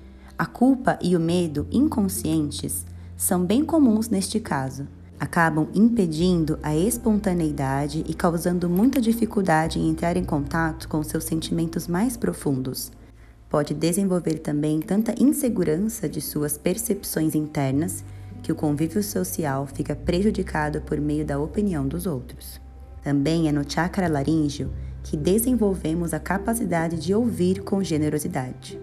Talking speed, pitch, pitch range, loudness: 130 wpm, 160 Hz, 145-190 Hz, -24 LUFS